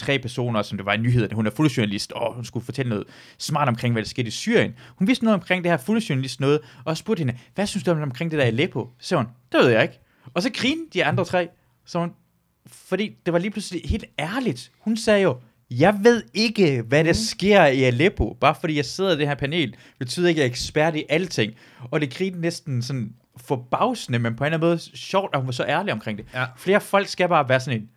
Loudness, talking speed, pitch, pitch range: -22 LUFS, 245 wpm, 145 Hz, 125-180 Hz